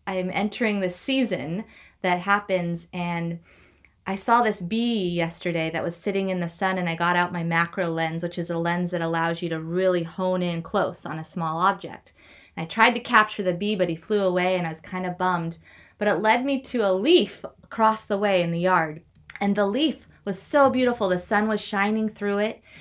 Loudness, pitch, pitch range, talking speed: -24 LUFS, 185 Hz, 170-210 Hz, 220 wpm